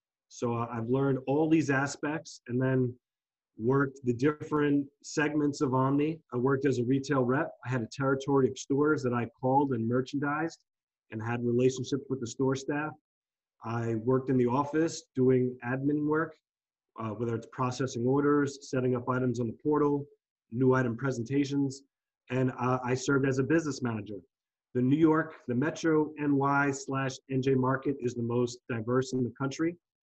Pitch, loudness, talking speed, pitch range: 135 Hz, -30 LUFS, 170 wpm, 125-145 Hz